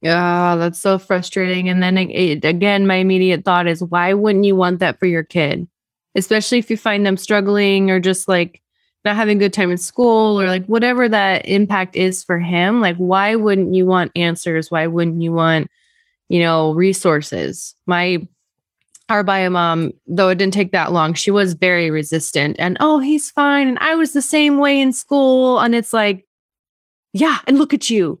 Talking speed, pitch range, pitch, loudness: 195 wpm, 175-220 Hz, 190 Hz, -16 LUFS